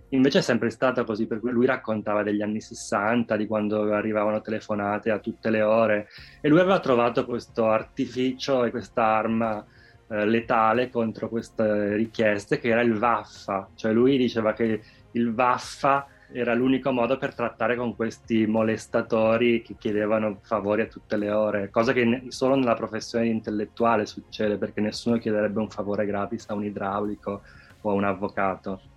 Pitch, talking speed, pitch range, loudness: 110 Hz, 165 wpm, 105-120 Hz, -25 LUFS